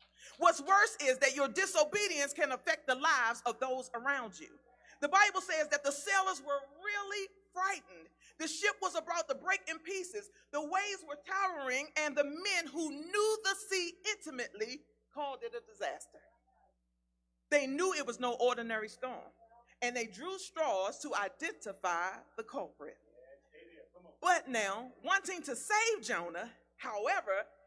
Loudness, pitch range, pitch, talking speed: -34 LUFS, 250-385 Hz, 305 Hz, 150 wpm